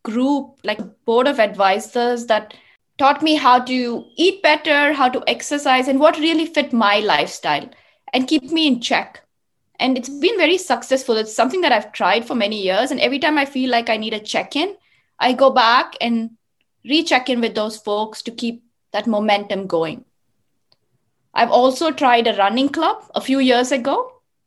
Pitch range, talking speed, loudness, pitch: 225-290 Hz, 180 wpm, -18 LUFS, 255 Hz